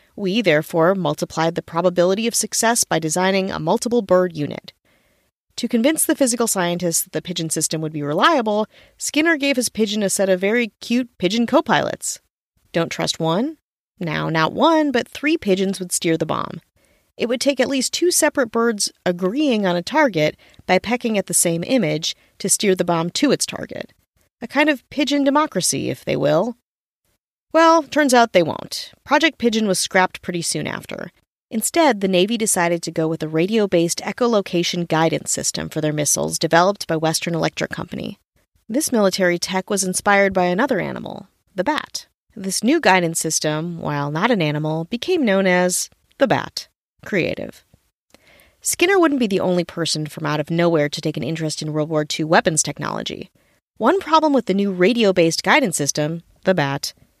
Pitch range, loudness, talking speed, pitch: 165-240 Hz, -19 LUFS, 180 wpm, 185 Hz